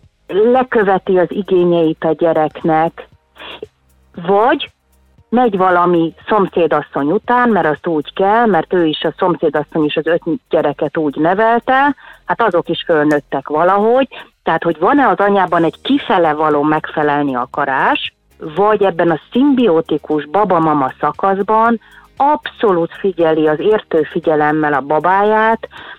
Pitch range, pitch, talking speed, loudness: 155-215 Hz, 170 Hz, 120 wpm, -14 LUFS